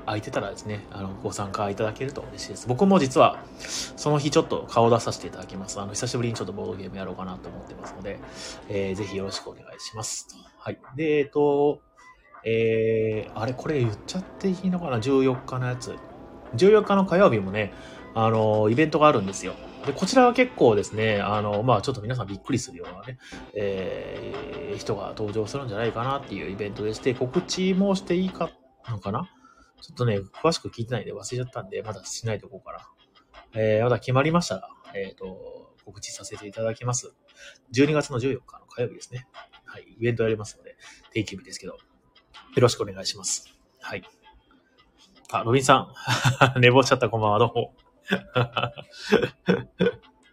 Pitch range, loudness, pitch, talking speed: 105-140 Hz, -25 LUFS, 120 Hz, 390 characters per minute